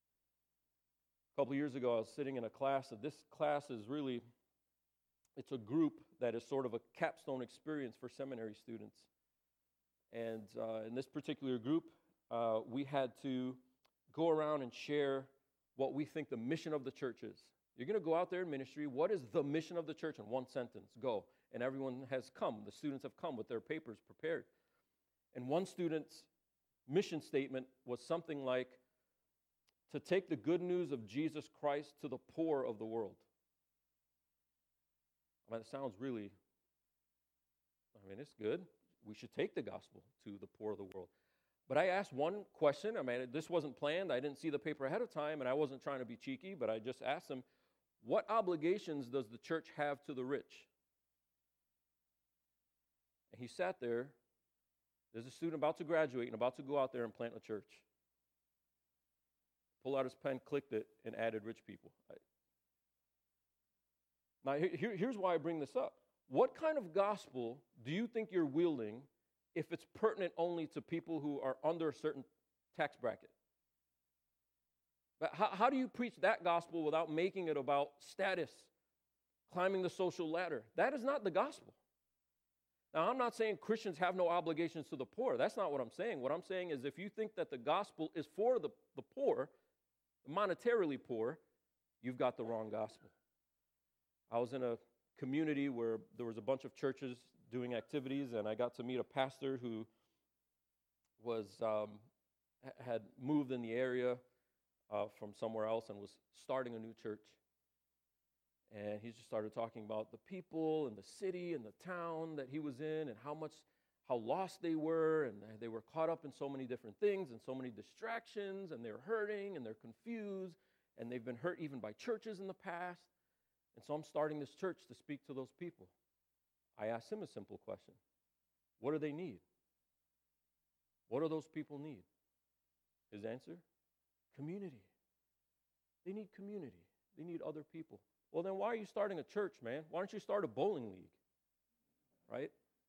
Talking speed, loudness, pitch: 180 wpm, -42 LUFS, 130 Hz